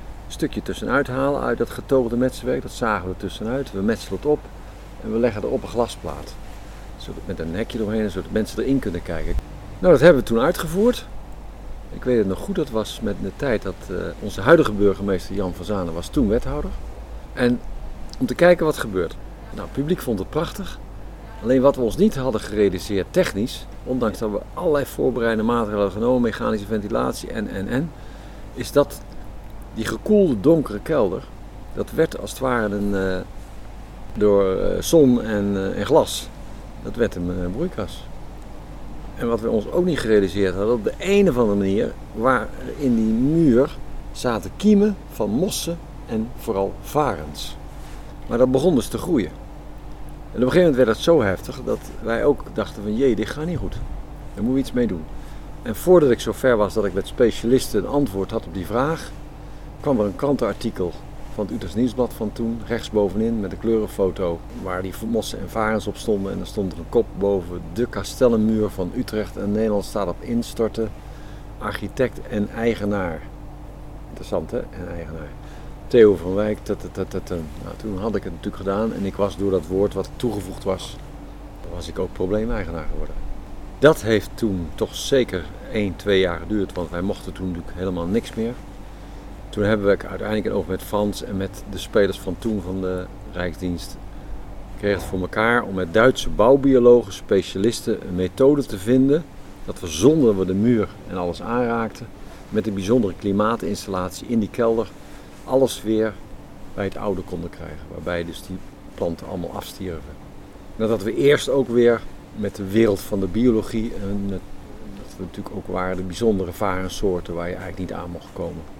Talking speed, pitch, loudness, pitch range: 180 wpm, 105 Hz, -22 LUFS, 95-120 Hz